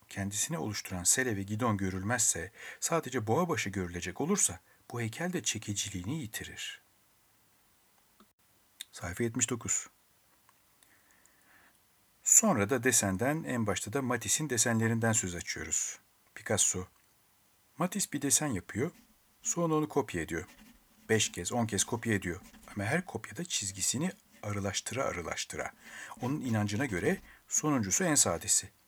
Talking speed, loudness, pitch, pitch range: 115 wpm, -31 LUFS, 115 Hz, 100-135 Hz